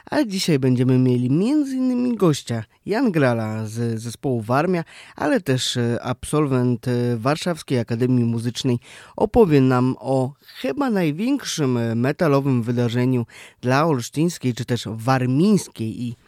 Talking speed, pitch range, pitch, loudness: 115 wpm, 120-160 Hz, 130 Hz, -21 LUFS